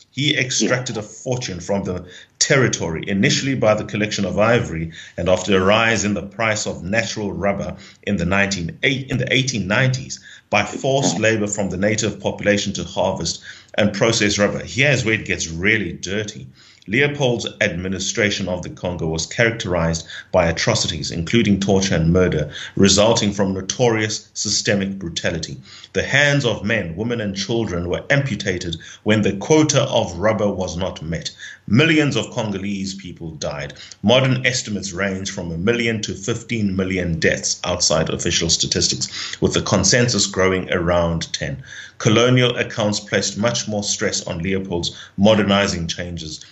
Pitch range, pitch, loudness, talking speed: 95-115 Hz, 105 Hz, -19 LUFS, 150 wpm